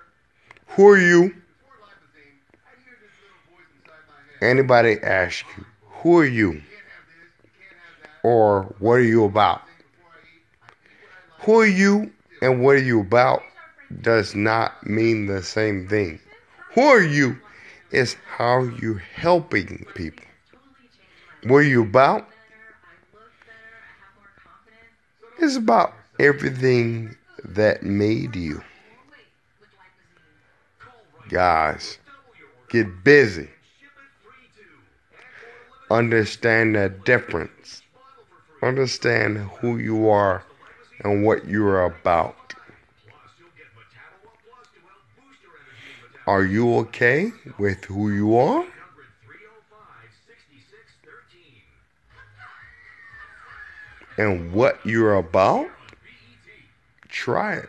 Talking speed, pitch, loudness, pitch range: 80 wpm, 120 Hz, -19 LUFS, 105-175 Hz